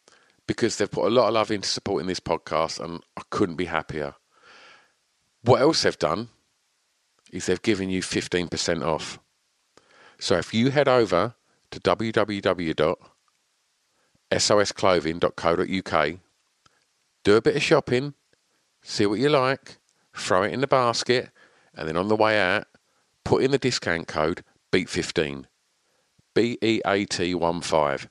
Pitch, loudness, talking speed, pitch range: 95 Hz, -24 LUFS, 130 wpm, 85-115 Hz